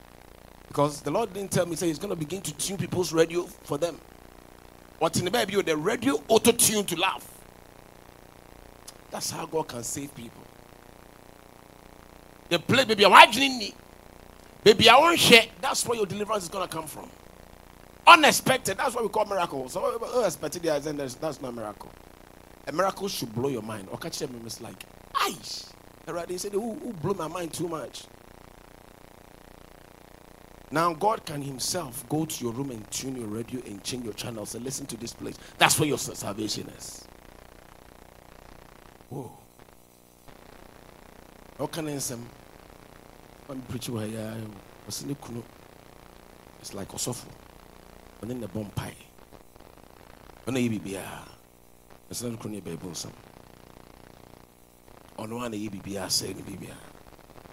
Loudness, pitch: -25 LUFS, 115 Hz